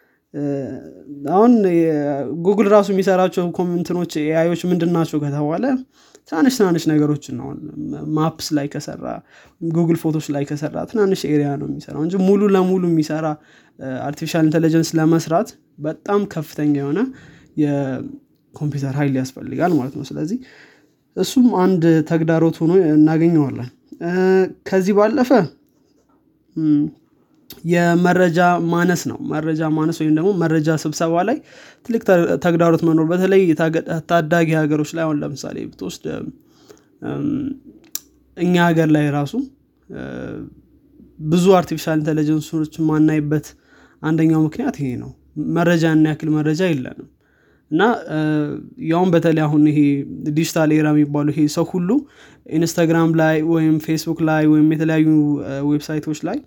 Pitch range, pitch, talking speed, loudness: 150-175 Hz, 160 Hz, 110 wpm, -18 LUFS